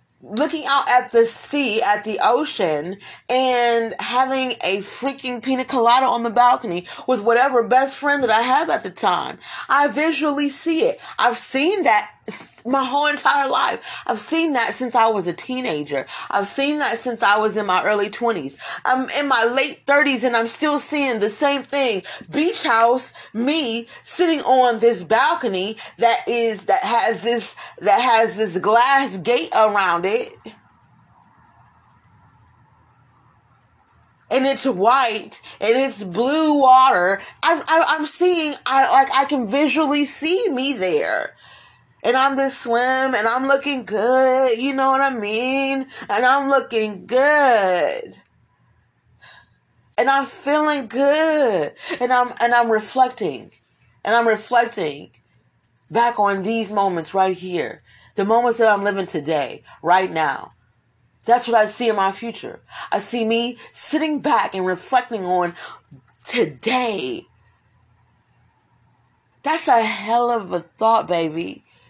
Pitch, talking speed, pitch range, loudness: 240 Hz, 145 wpm, 205-275 Hz, -18 LUFS